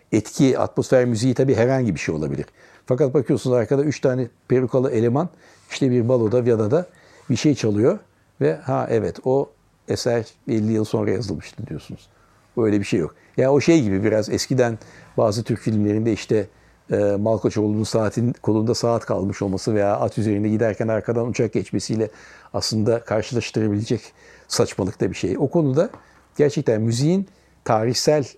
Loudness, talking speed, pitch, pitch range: -21 LUFS, 150 wpm, 115 Hz, 110-130 Hz